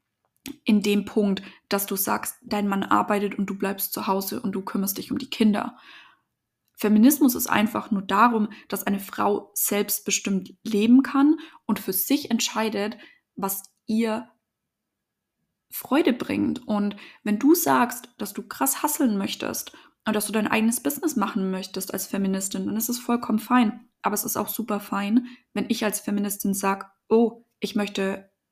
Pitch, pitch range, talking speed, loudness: 215 Hz, 200-240 Hz, 165 wpm, -24 LUFS